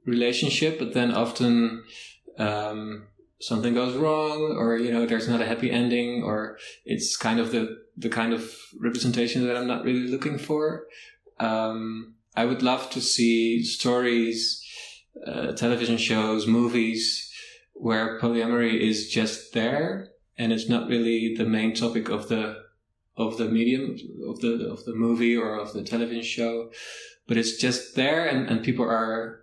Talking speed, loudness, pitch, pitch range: 155 wpm, -25 LUFS, 115 Hz, 115-120 Hz